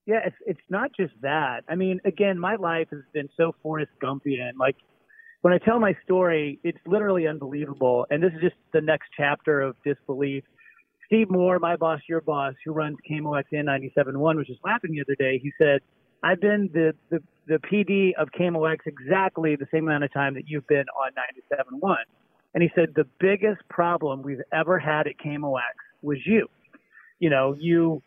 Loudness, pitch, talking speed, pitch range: -25 LUFS, 155 Hz, 195 wpm, 140-185 Hz